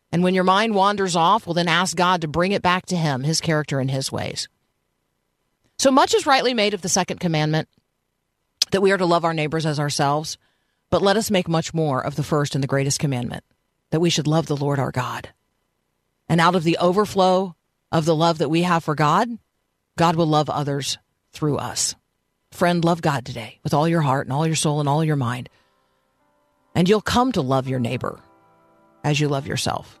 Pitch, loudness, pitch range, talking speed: 155 Hz, -21 LUFS, 135-175 Hz, 210 wpm